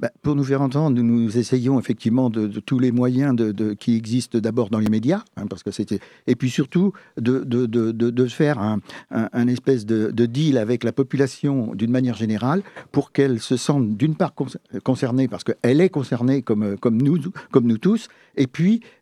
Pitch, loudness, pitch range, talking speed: 125 Hz, -21 LUFS, 115-140 Hz, 210 wpm